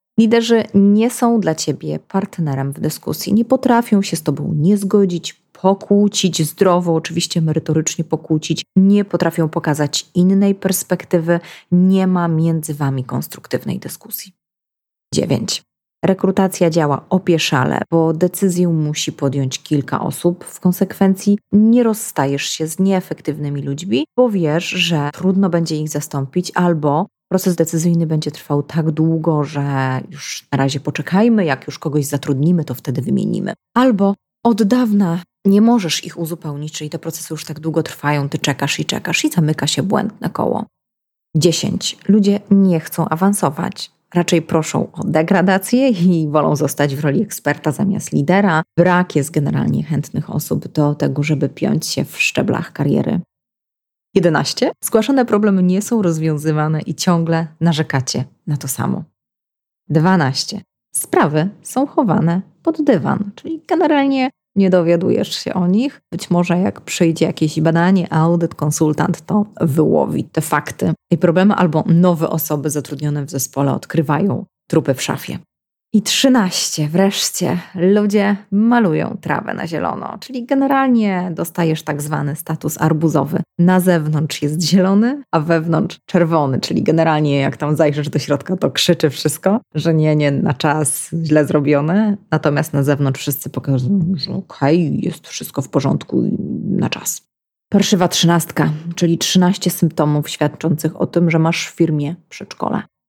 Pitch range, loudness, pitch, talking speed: 150-195 Hz, -17 LUFS, 170 Hz, 140 wpm